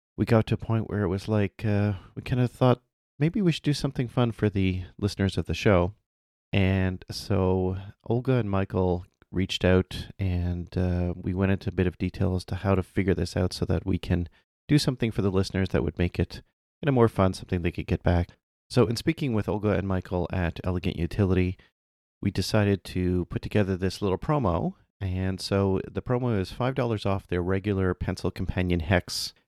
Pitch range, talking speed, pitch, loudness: 90-110 Hz, 210 wpm, 95 Hz, -27 LUFS